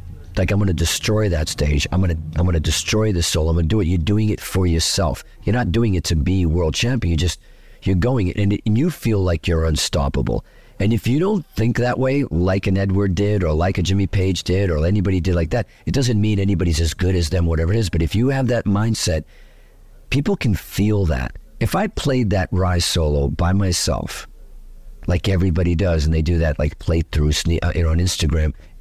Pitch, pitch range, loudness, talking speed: 90 Hz, 85-105 Hz, -19 LUFS, 215 wpm